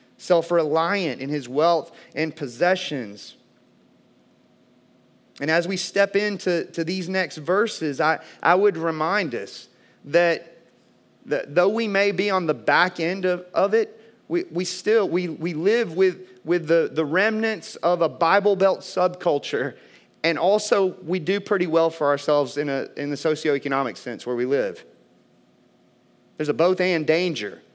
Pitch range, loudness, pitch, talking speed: 150-185 Hz, -22 LUFS, 170 Hz, 155 wpm